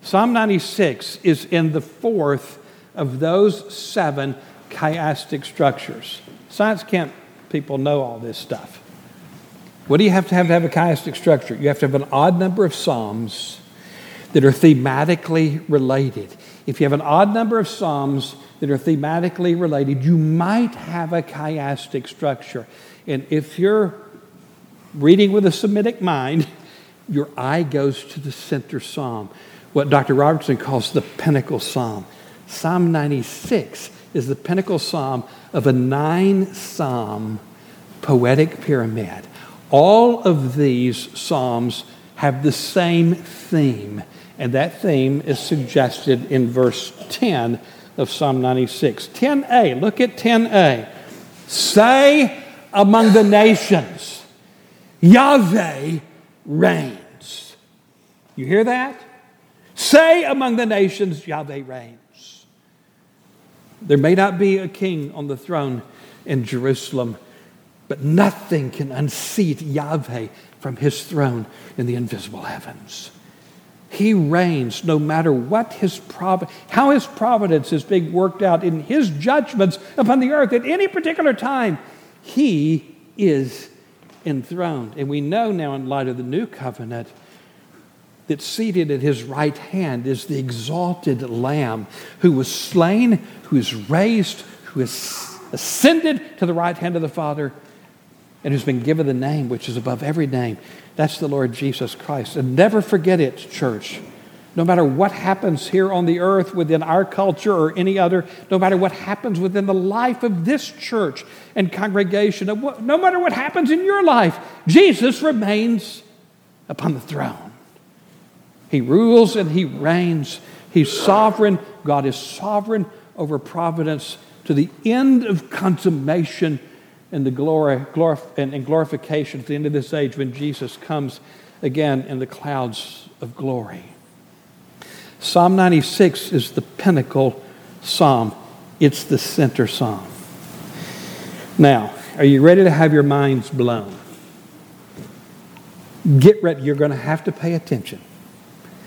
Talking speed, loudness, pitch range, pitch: 140 wpm, -18 LUFS, 140-200 Hz, 160 Hz